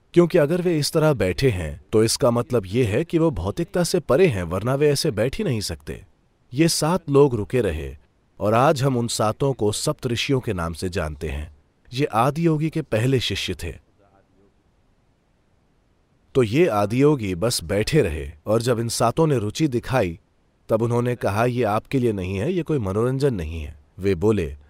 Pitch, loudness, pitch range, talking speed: 115 Hz, -22 LUFS, 95-140 Hz, 190 wpm